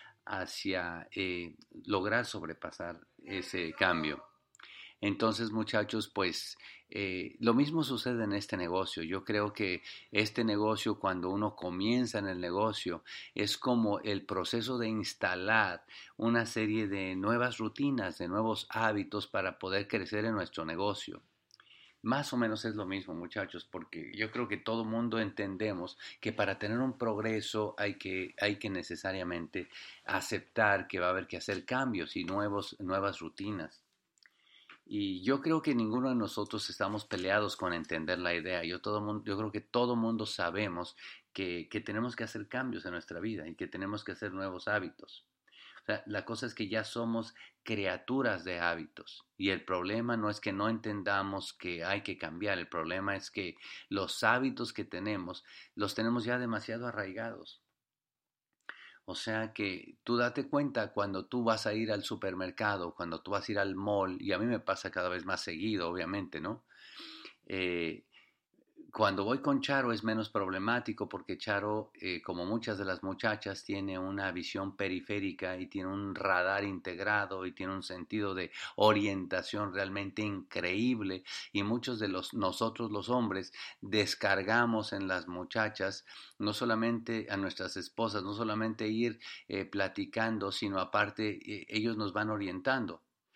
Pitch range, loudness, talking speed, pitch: 95-115 Hz, -35 LUFS, 160 wpm, 105 Hz